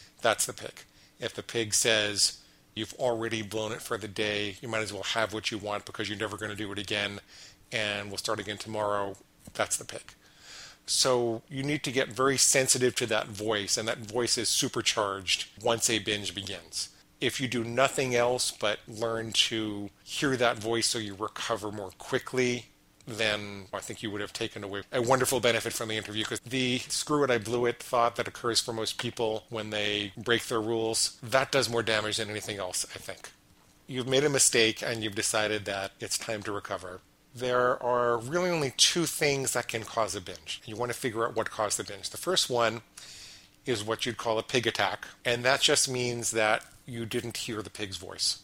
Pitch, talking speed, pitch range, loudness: 115 Hz, 205 wpm, 105-120 Hz, -29 LUFS